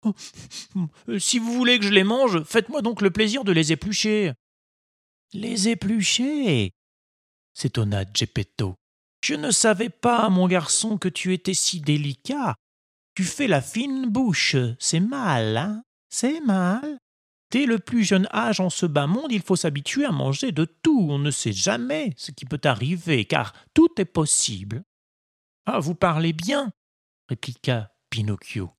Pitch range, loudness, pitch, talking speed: 135-225 Hz, -23 LUFS, 185 Hz, 160 wpm